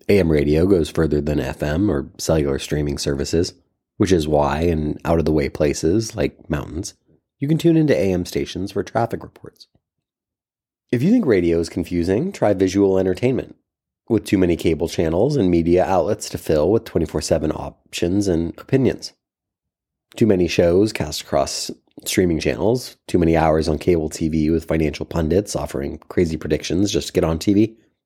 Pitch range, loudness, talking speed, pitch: 75-100 Hz, -20 LUFS, 170 wpm, 85 Hz